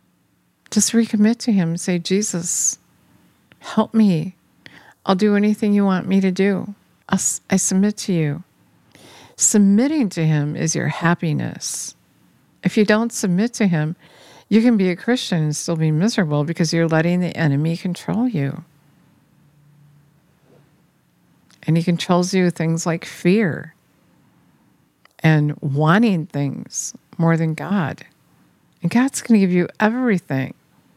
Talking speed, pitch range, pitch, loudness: 140 wpm, 160-205 Hz, 175 Hz, -19 LUFS